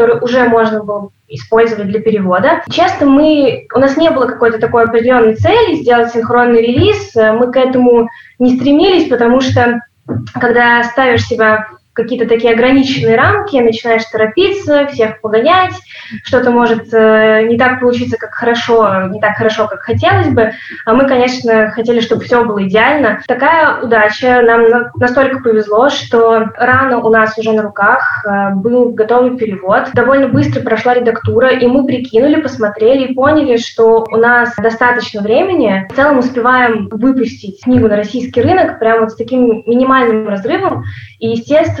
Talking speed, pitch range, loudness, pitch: 150 wpm, 225-255 Hz, -10 LUFS, 235 Hz